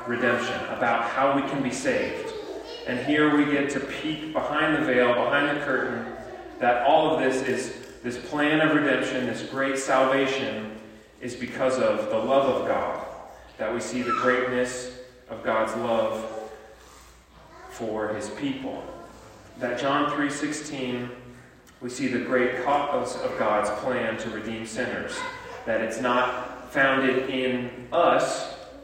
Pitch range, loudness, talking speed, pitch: 120-145 Hz, -25 LUFS, 145 wpm, 130 Hz